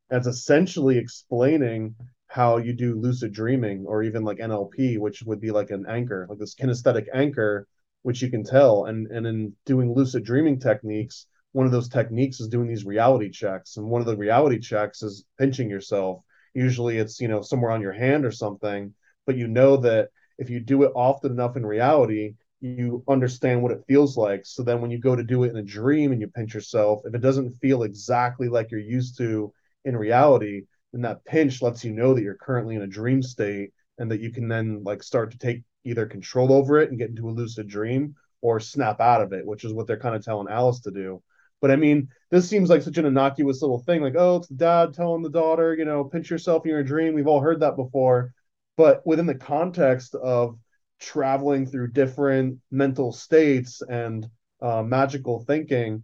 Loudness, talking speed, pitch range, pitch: -23 LUFS, 210 wpm, 110-135 Hz, 125 Hz